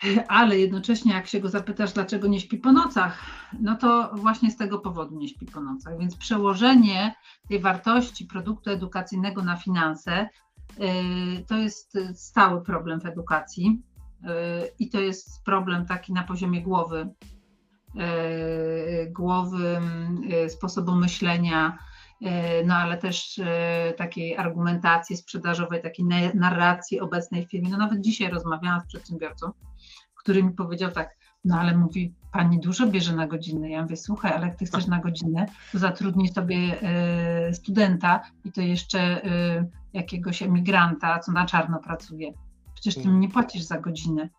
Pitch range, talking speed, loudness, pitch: 170-200 Hz, 140 wpm, -25 LUFS, 180 Hz